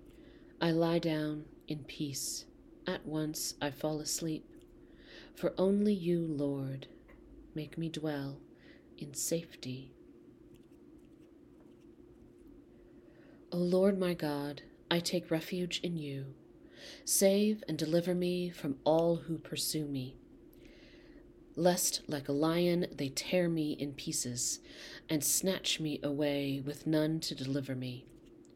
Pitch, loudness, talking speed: 170 Hz, -34 LUFS, 115 wpm